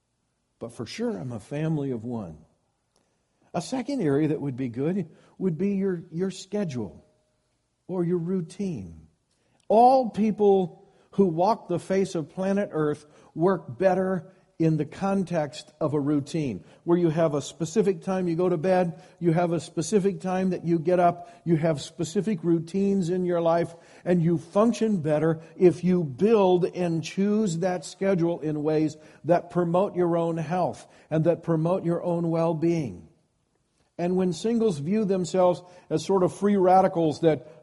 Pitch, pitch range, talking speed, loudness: 175 Hz, 160-190 Hz, 165 wpm, -25 LUFS